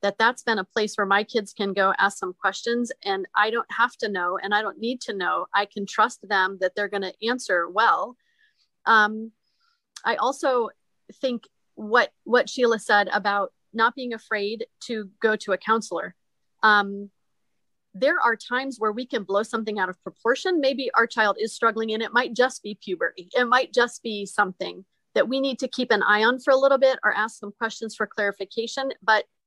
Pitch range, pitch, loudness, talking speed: 205-250 Hz, 225 Hz, -23 LUFS, 200 wpm